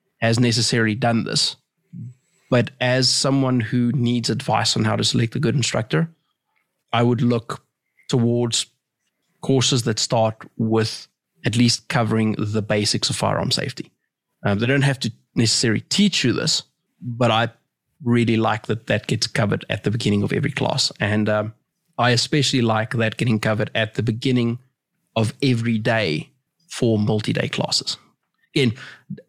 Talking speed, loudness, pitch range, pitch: 150 wpm, -20 LUFS, 110-130 Hz, 120 Hz